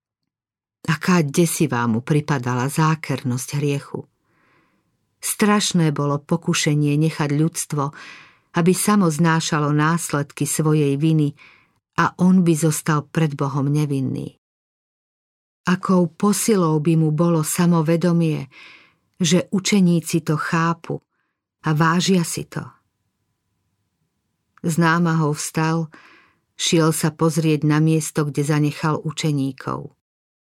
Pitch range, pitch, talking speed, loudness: 145-170 Hz, 155 Hz, 95 wpm, -20 LUFS